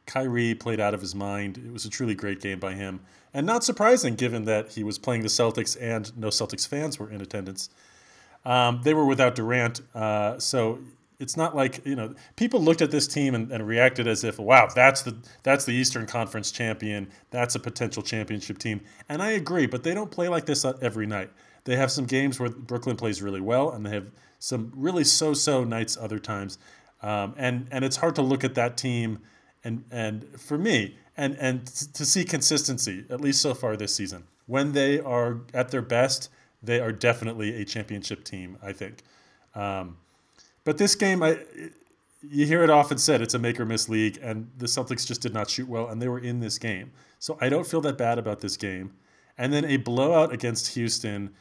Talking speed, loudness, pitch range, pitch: 210 wpm, -25 LUFS, 110-135 Hz, 120 Hz